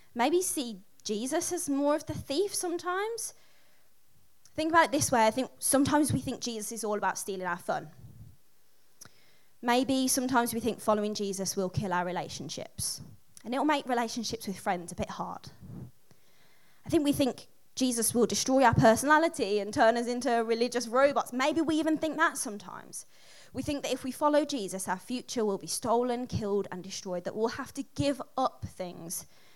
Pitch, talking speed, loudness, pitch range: 240 Hz, 180 wpm, -29 LUFS, 205-285 Hz